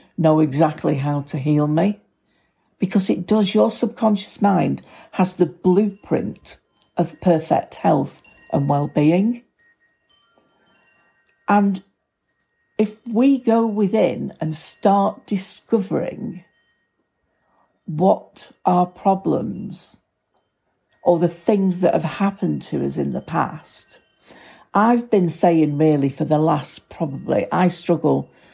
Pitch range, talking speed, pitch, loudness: 160-210 Hz, 110 wpm, 185 Hz, -20 LUFS